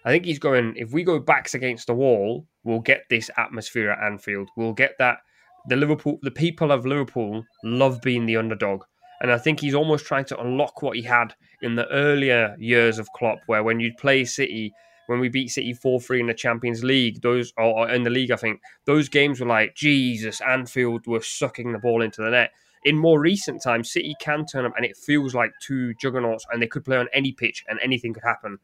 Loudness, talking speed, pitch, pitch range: -22 LUFS, 225 wpm, 125 Hz, 115-140 Hz